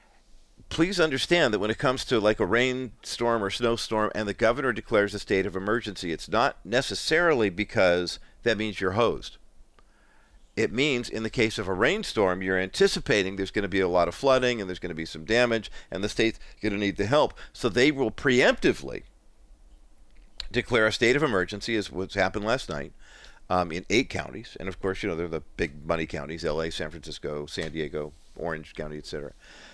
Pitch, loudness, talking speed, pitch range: 100 Hz, -26 LUFS, 195 wpm, 85-115 Hz